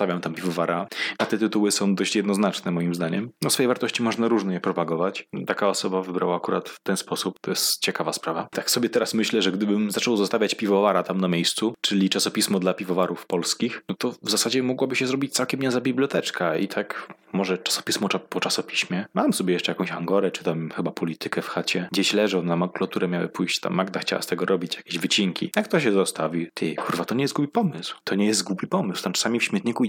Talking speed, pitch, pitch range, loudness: 215 wpm, 100 Hz, 90-115 Hz, -24 LUFS